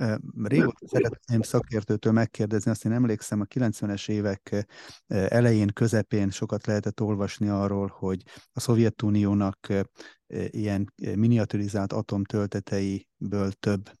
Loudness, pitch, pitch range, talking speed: -27 LUFS, 105 Hz, 100-110 Hz, 100 wpm